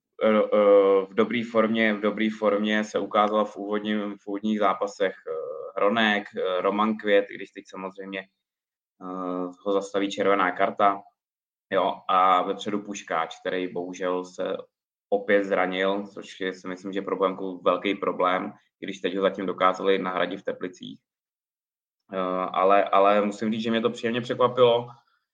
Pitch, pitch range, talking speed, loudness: 100 Hz, 95-110 Hz, 135 wpm, -25 LUFS